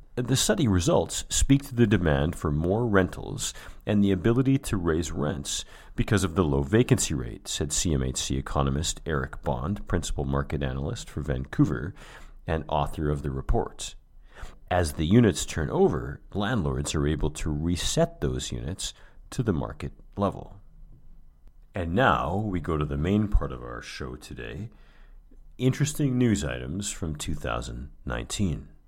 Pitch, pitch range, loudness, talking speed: 80 Hz, 70-100 Hz, -27 LUFS, 145 wpm